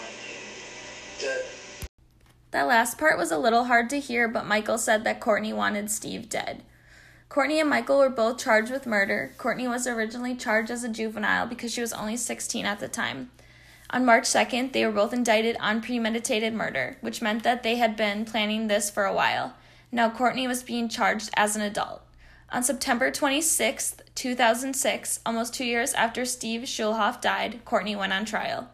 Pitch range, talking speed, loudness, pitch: 215-250 Hz, 180 wpm, -25 LUFS, 230 Hz